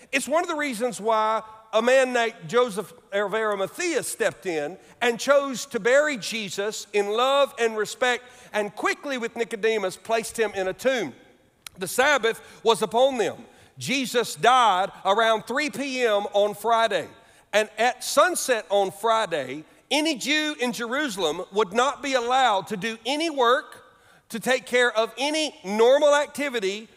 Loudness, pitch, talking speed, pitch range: -23 LUFS, 235 Hz, 150 wpm, 215-265 Hz